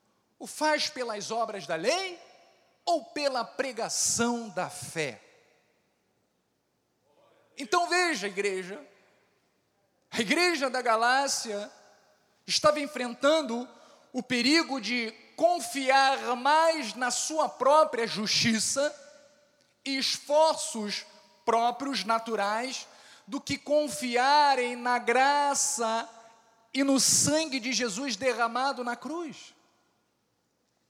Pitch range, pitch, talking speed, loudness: 230-295 Hz, 265 Hz, 90 wpm, -27 LUFS